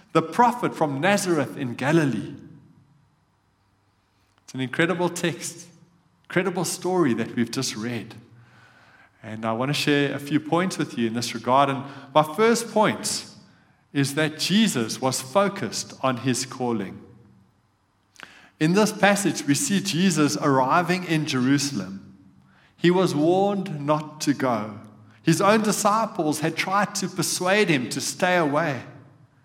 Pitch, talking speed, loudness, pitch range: 150 Hz, 135 wpm, -23 LUFS, 120-175 Hz